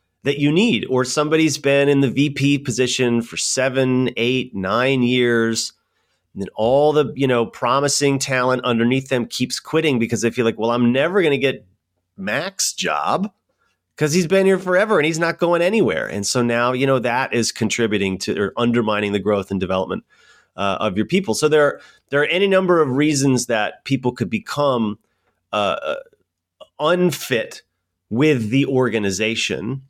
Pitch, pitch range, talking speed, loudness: 130 Hz, 115-145 Hz, 175 wpm, -19 LUFS